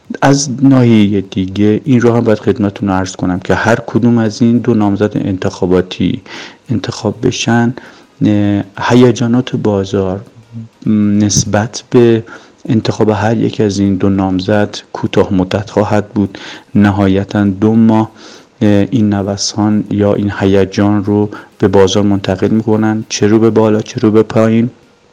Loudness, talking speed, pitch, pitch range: -12 LUFS, 135 wpm, 105 Hz, 100-115 Hz